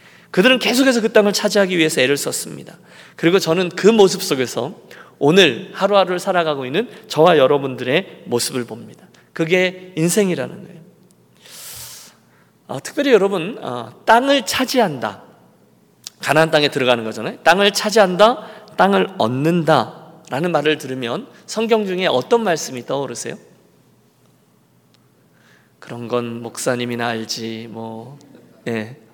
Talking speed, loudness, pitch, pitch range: 290 characters per minute, -17 LUFS, 160 Hz, 125-195 Hz